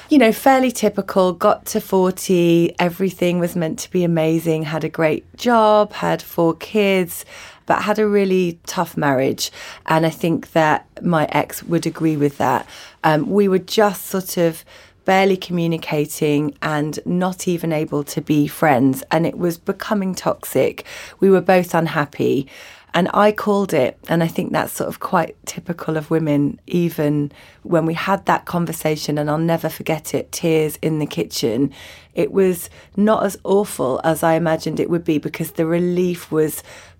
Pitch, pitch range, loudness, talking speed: 170 Hz, 155-190 Hz, -19 LUFS, 170 wpm